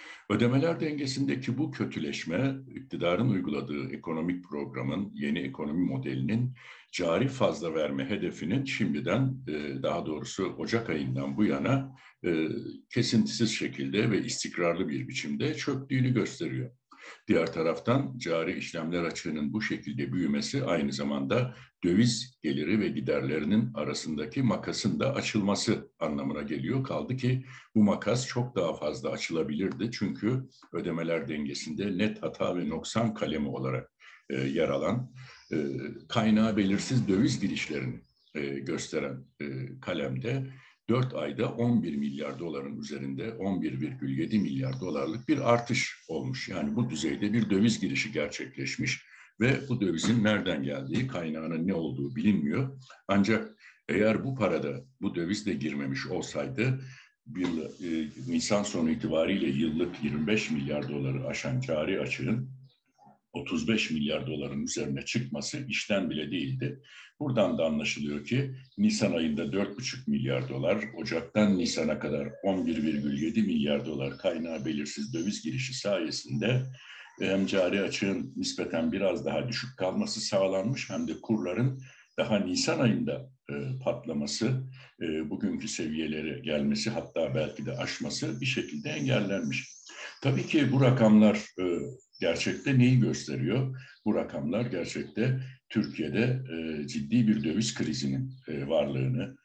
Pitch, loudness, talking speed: 95 Hz, -30 LUFS, 120 wpm